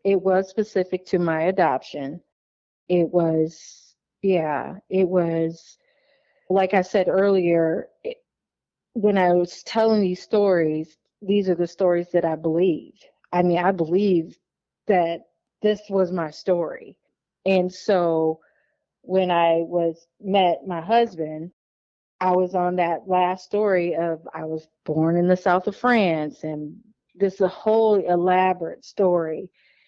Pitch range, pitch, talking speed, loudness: 165-195 Hz, 180 Hz, 135 wpm, -22 LUFS